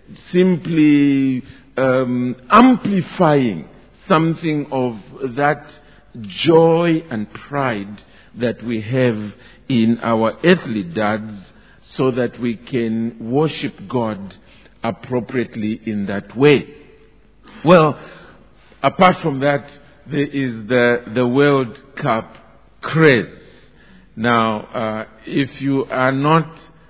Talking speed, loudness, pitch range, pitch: 95 wpm, -17 LUFS, 115-145 Hz, 130 Hz